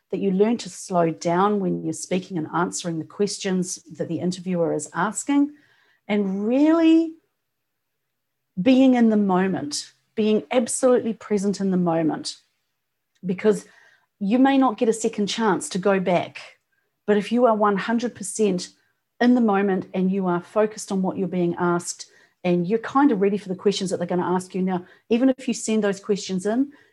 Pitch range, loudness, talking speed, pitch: 180-225 Hz, -22 LUFS, 180 wpm, 200 Hz